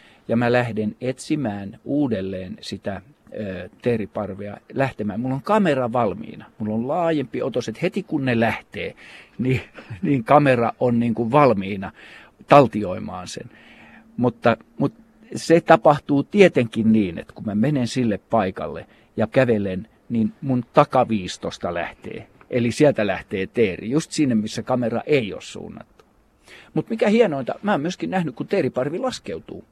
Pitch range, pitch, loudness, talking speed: 110-145 Hz, 125 Hz, -21 LUFS, 140 wpm